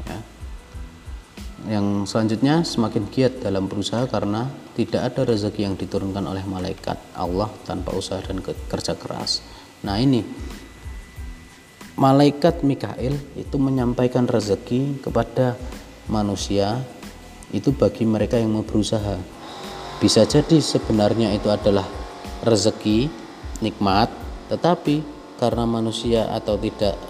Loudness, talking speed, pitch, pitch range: -22 LUFS, 105 wpm, 110 Hz, 100-125 Hz